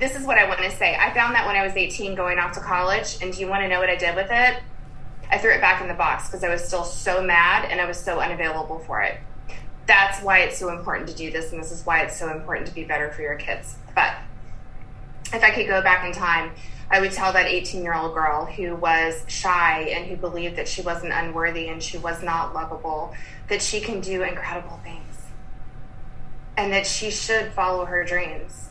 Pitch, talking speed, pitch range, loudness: 175 Hz, 240 wpm, 160-190 Hz, -22 LUFS